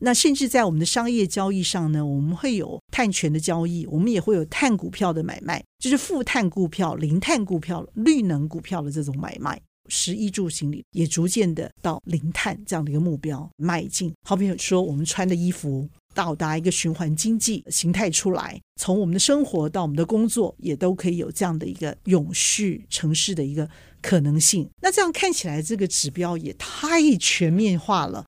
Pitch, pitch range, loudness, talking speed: 180 Hz, 160-205 Hz, -23 LUFS, 300 characters per minute